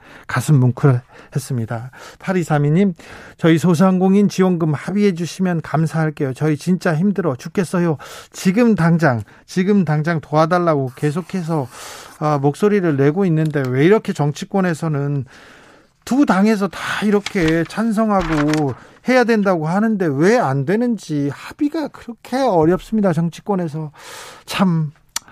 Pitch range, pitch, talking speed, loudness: 150-200 Hz, 170 Hz, 280 characters per minute, -17 LUFS